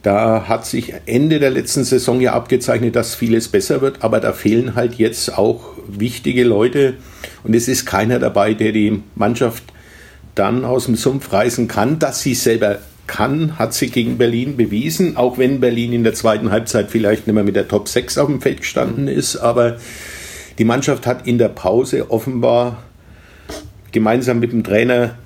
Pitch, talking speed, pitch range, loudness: 115 Hz, 180 wpm, 110-125 Hz, -16 LUFS